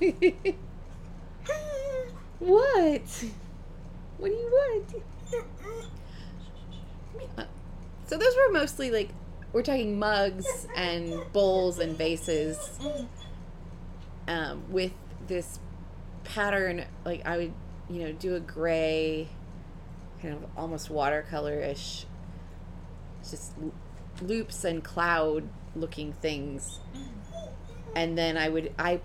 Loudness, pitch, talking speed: -30 LUFS, 160 Hz, 95 wpm